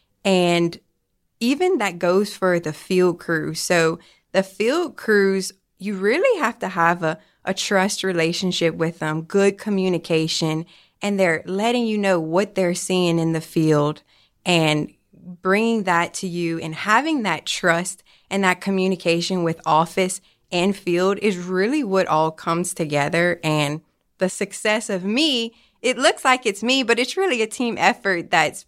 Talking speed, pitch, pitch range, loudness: 155 wpm, 185 Hz, 165-205 Hz, -21 LUFS